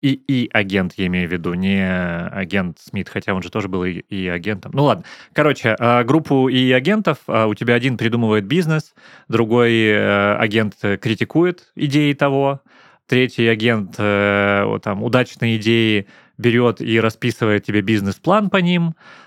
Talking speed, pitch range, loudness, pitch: 145 wpm, 100-135 Hz, -18 LUFS, 115 Hz